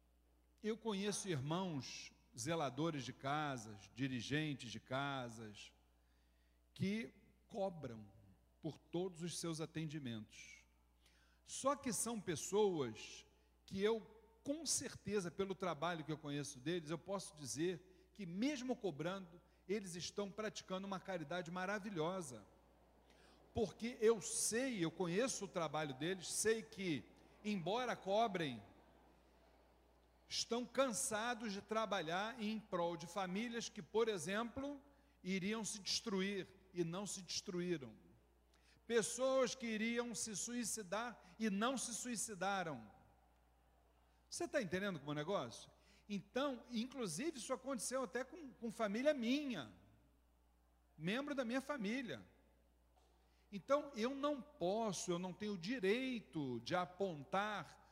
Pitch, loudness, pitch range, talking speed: 190 Hz, -43 LUFS, 140-225 Hz, 115 wpm